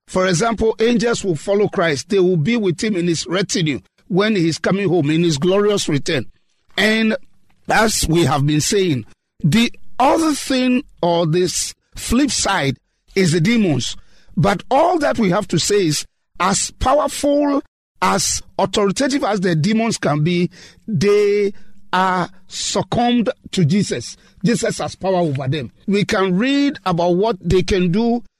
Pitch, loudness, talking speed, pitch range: 195 Hz, -17 LUFS, 155 wpm, 170-225 Hz